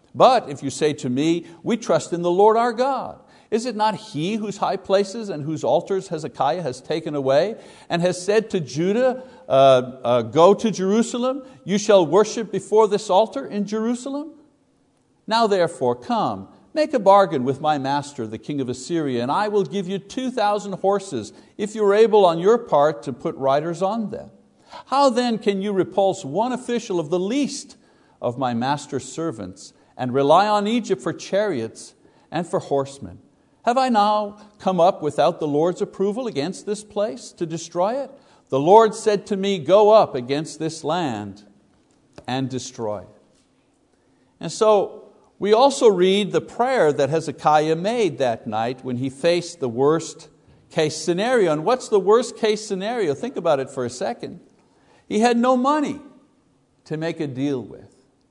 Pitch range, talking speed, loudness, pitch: 150-220 Hz, 175 wpm, -21 LUFS, 190 Hz